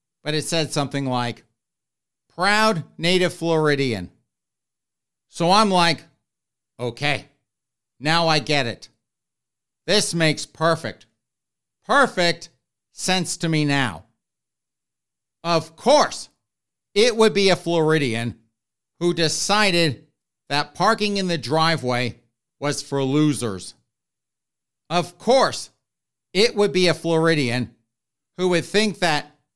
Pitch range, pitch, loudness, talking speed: 125-175 Hz, 155 Hz, -21 LUFS, 105 wpm